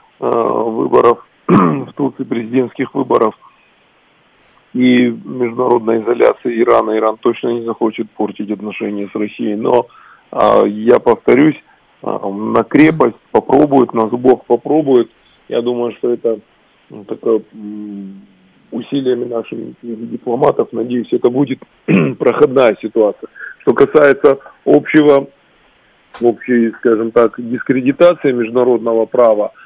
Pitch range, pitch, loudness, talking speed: 110-125 Hz, 120 Hz, -13 LUFS, 95 wpm